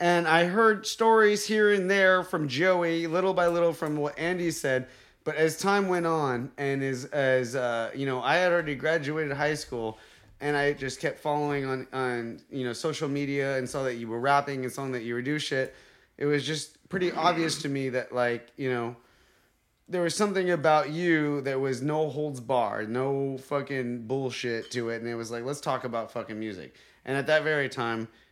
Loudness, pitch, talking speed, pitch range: -27 LUFS, 140 Hz, 205 wpm, 125-160 Hz